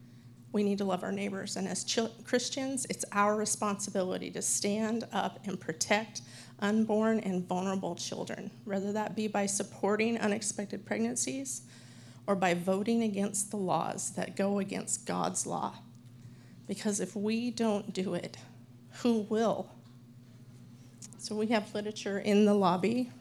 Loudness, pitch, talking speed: -32 LUFS, 200 Hz, 140 wpm